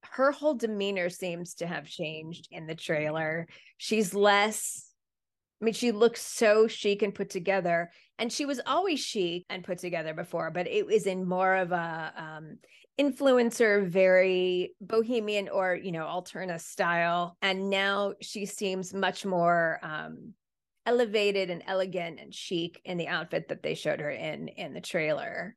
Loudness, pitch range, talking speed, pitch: -29 LUFS, 175-215 Hz, 160 wpm, 190 Hz